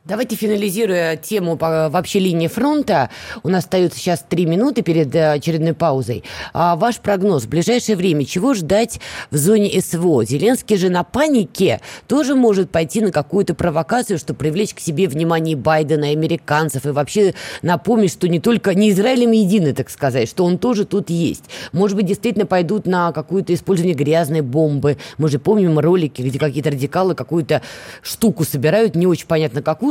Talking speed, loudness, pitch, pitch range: 170 wpm, -17 LUFS, 175 Hz, 155-205 Hz